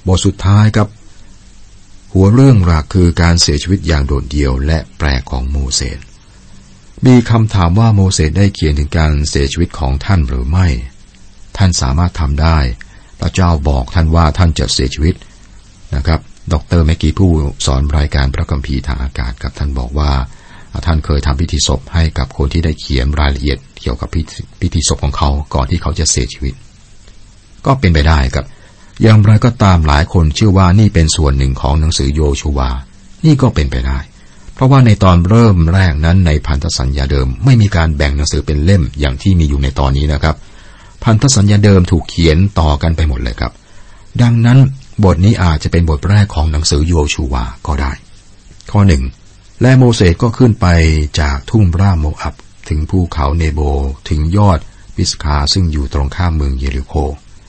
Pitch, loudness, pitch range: 80 Hz, -12 LUFS, 70-95 Hz